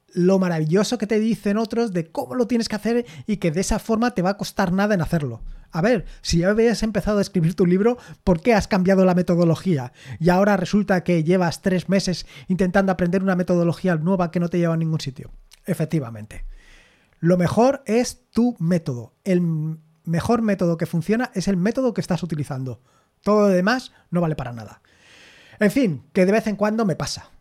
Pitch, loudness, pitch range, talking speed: 185 Hz, -21 LUFS, 165-210 Hz, 200 wpm